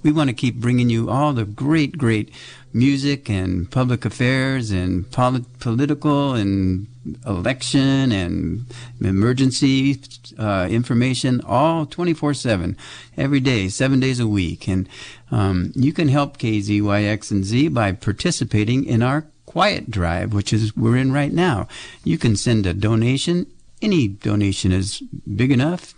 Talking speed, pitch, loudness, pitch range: 145 wpm, 120 Hz, -20 LUFS, 105-135 Hz